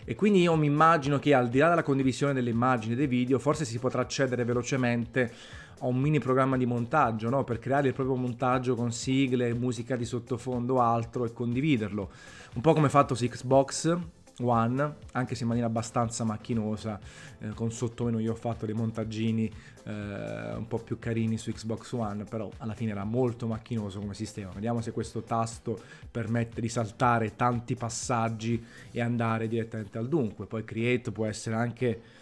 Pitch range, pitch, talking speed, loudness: 115-130 Hz, 120 Hz, 185 wpm, -29 LUFS